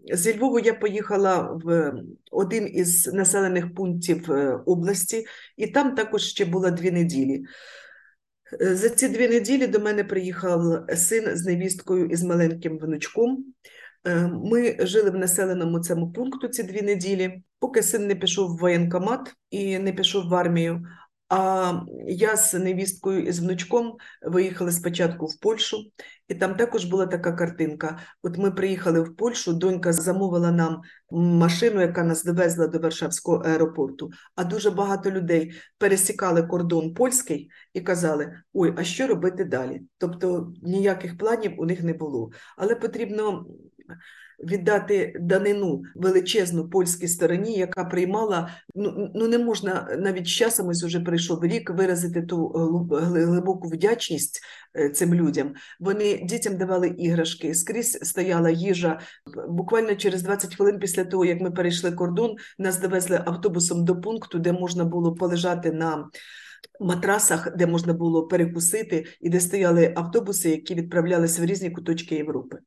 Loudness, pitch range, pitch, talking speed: -24 LUFS, 170-200 Hz, 180 Hz, 140 wpm